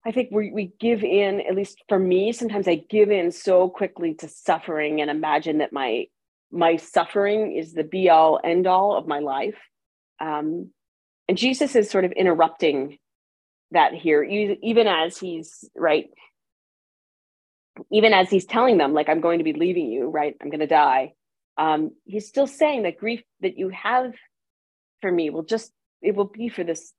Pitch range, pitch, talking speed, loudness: 160-215 Hz, 185 Hz, 175 wpm, -22 LUFS